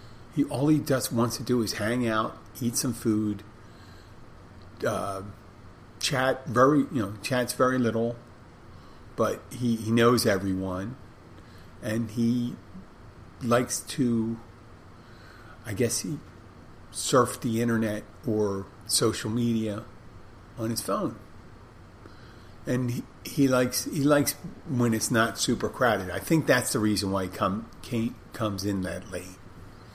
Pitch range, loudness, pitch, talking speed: 100-120 Hz, -27 LUFS, 115 Hz, 130 wpm